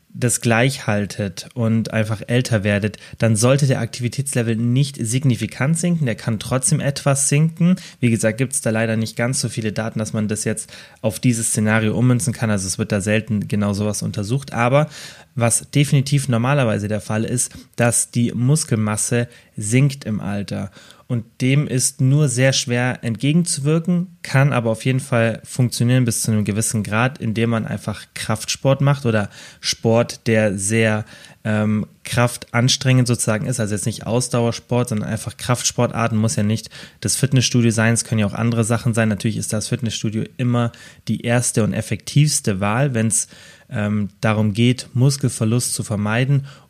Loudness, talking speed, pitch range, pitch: -19 LUFS, 165 wpm, 110-130 Hz, 115 Hz